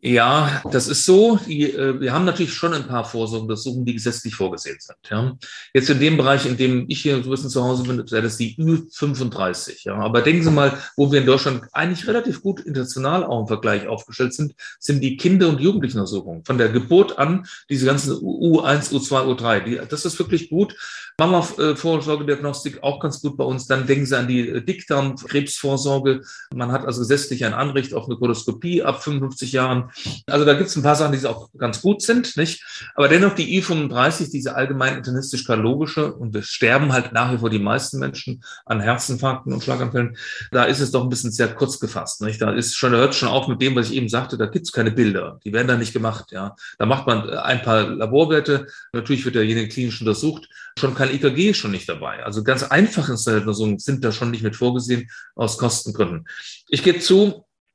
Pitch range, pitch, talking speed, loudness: 120-150 Hz, 135 Hz, 205 wpm, -20 LUFS